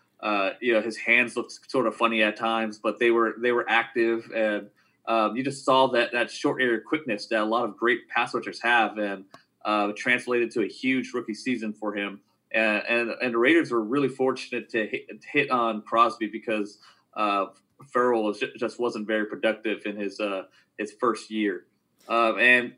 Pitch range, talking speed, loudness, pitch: 105-120 Hz, 200 wpm, -25 LUFS, 115 Hz